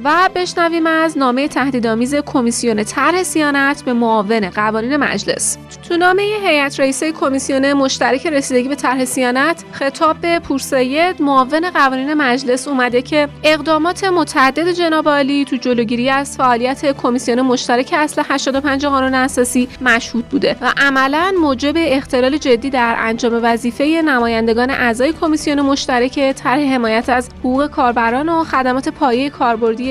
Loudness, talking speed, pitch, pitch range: -15 LUFS, 130 wpm, 275 Hz, 250-300 Hz